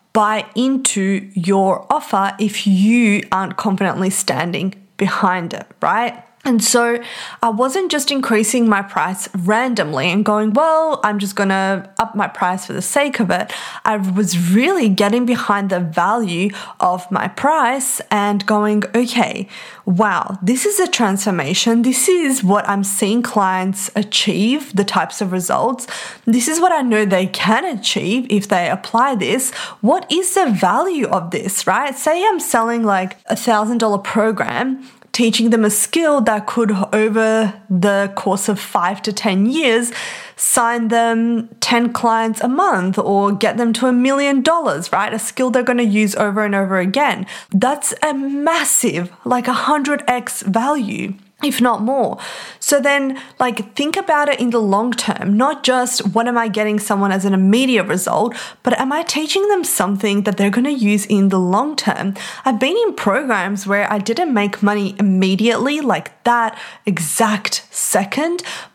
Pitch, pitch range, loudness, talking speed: 220 Hz, 200-250 Hz, -16 LUFS, 165 wpm